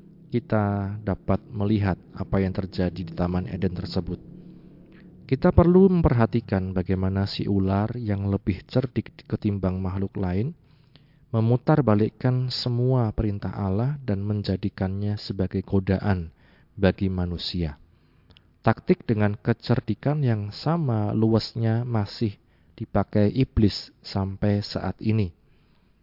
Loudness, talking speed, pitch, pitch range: -25 LUFS, 105 wpm, 105 Hz, 95-125 Hz